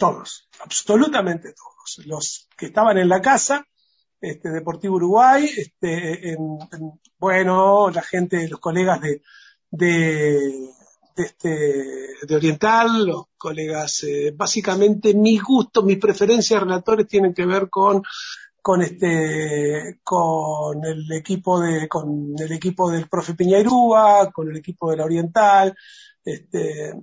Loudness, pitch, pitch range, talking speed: -19 LUFS, 180 Hz, 160-210 Hz, 130 wpm